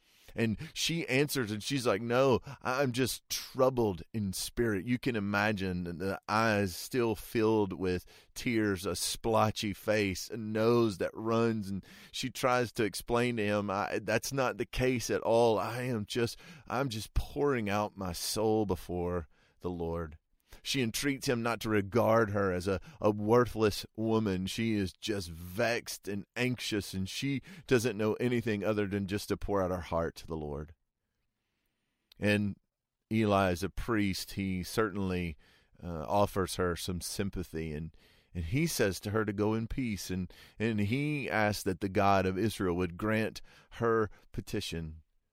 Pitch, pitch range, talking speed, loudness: 105 Hz, 95-115 Hz, 165 wpm, -32 LUFS